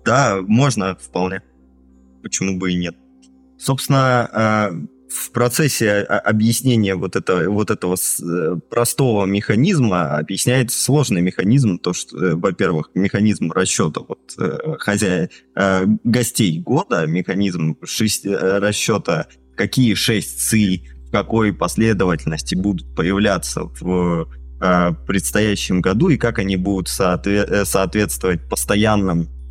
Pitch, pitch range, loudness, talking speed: 95 Hz, 85-110 Hz, -18 LUFS, 100 wpm